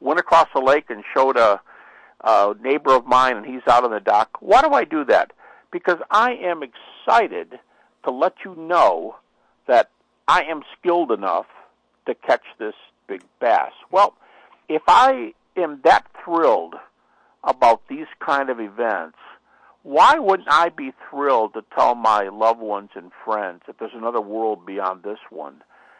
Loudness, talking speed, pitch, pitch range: -19 LUFS, 160 wpm, 130 Hz, 110-175 Hz